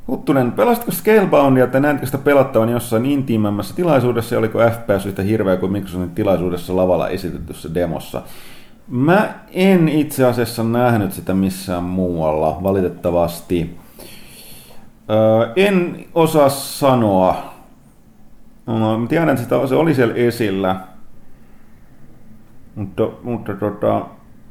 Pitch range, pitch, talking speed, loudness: 95-135 Hz, 110 Hz, 110 wpm, -17 LUFS